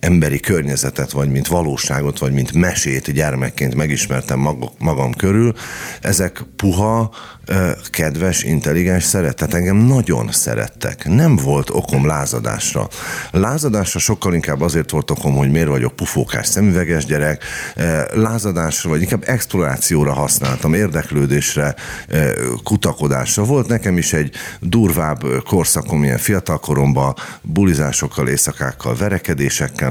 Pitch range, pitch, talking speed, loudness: 70-95 Hz, 80 Hz, 110 wpm, -17 LUFS